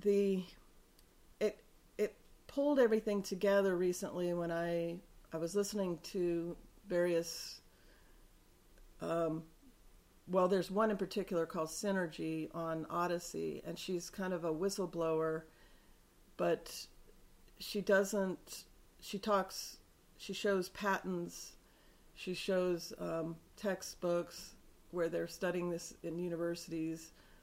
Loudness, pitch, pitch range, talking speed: -38 LUFS, 175 Hz, 165-195 Hz, 105 wpm